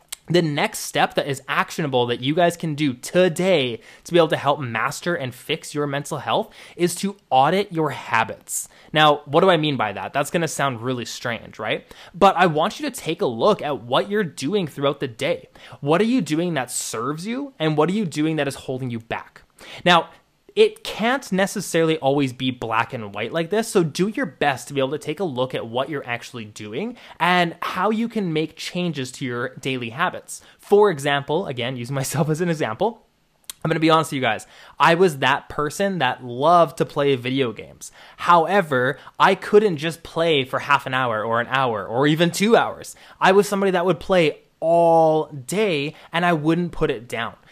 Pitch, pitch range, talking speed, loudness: 160 Hz, 135-185 Hz, 210 wpm, -21 LUFS